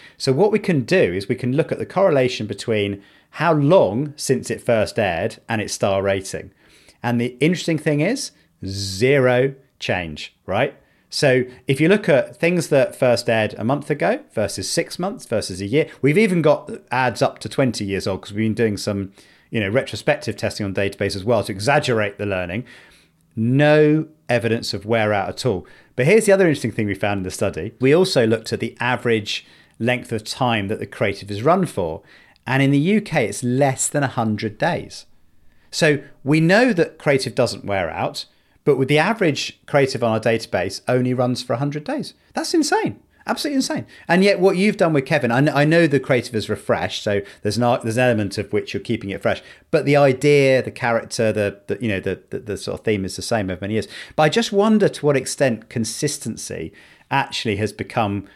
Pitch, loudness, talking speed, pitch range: 120 Hz, -20 LUFS, 205 wpm, 105-145 Hz